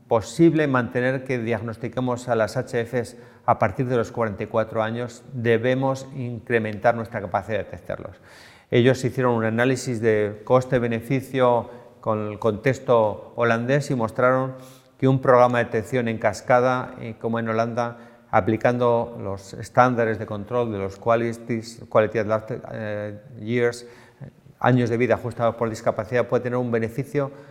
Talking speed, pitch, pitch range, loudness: 135 wpm, 120 Hz, 115-125 Hz, -23 LUFS